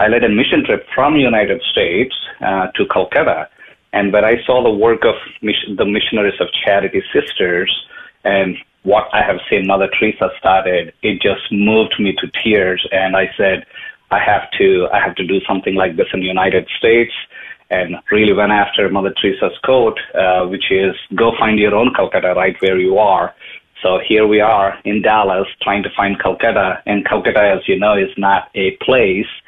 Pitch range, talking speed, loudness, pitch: 95-115 Hz, 190 wpm, -14 LUFS, 100 Hz